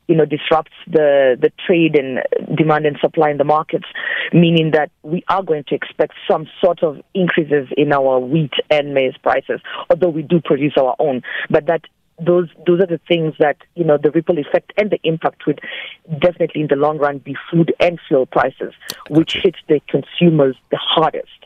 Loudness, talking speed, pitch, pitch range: -16 LUFS, 195 wpm, 160 Hz, 150-175 Hz